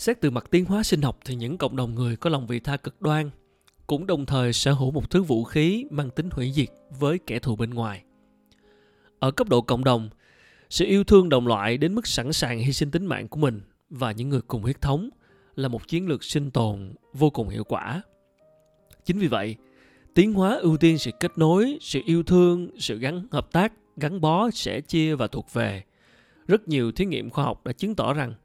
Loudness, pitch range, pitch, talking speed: -24 LUFS, 120-170 Hz, 140 Hz, 225 wpm